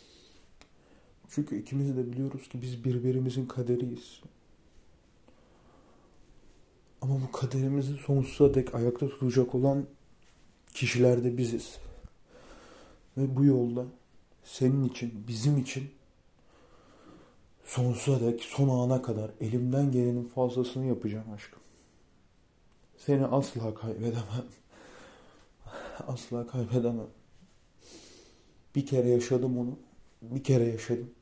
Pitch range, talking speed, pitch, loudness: 115-135 Hz, 90 wpm, 125 Hz, -30 LUFS